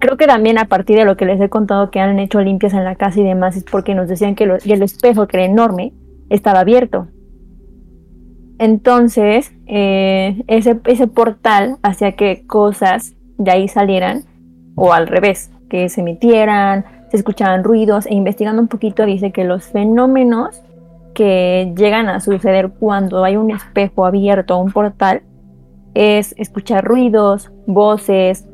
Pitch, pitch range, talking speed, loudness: 200 Hz, 185-215 Hz, 160 wpm, -13 LUFS